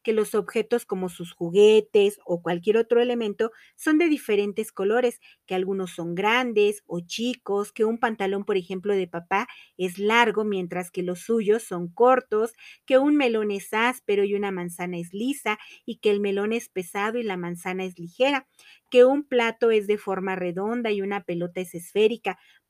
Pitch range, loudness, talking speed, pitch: 185-235 Hz, -24 LUFS, 180 wpm, 210 Hz